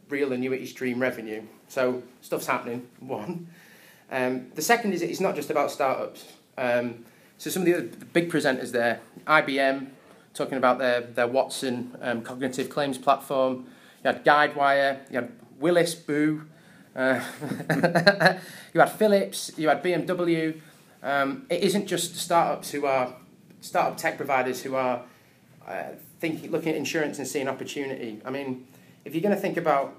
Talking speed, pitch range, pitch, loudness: 155 wpm, 130-165 Hz, 140 Hz, -26 LUFS